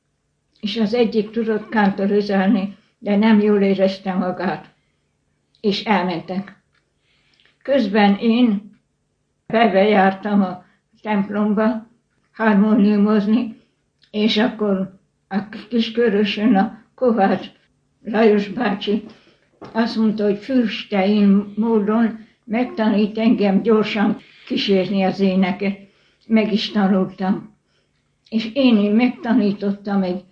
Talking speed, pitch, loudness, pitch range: 90 wpm, 210 Hz, -18 LUFS, 195-225 Hz